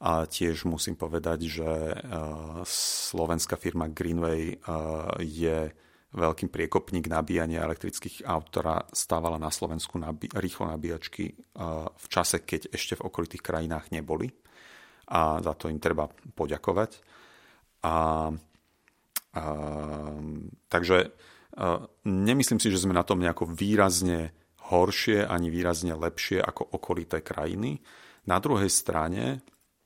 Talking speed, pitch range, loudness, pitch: 120 wpm, 80-85 Hz, -29 LUFS, 80 Hz